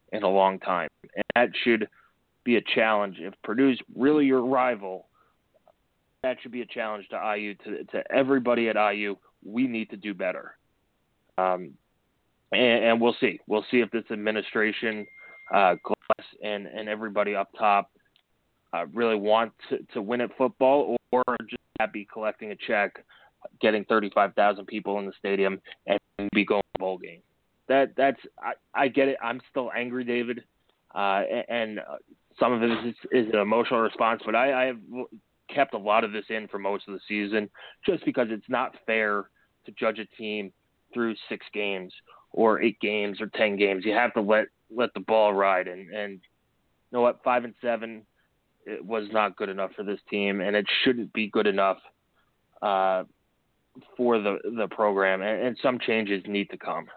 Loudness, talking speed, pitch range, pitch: -26 LUFS, 180 wpm, 100-120 Hz, 110 Hz